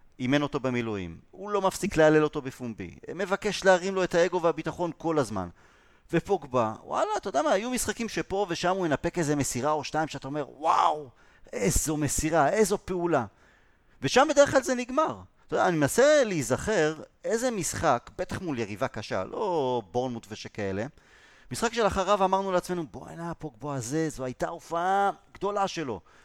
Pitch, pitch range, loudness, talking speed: 160 Hz, 130-190 Hz, -27 LUFS, 160 wpm